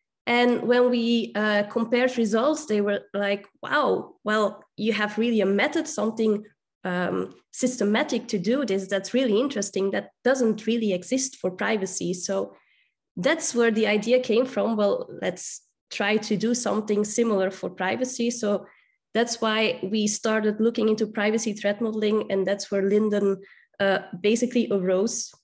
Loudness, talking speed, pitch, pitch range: -24 LUFS, 150 wpm, 215 Hz, 200-235 Hz